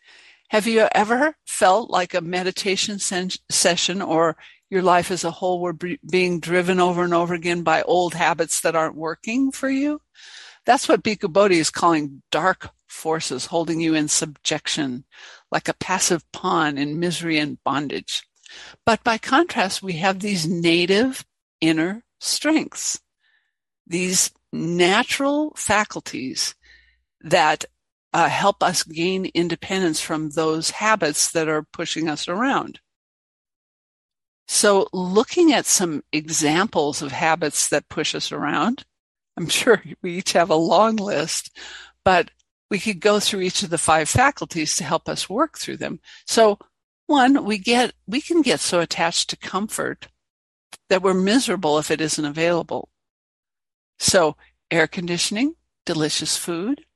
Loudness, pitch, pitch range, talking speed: -21 LUFS, 180 Hz, 160-215 Hz, 140 wpm